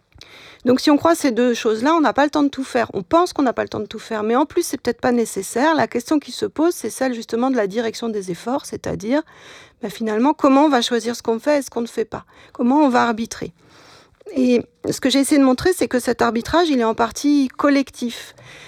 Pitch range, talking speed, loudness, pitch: 230-290 Hz, 260 wpm, -19 LUFS, 250 Hz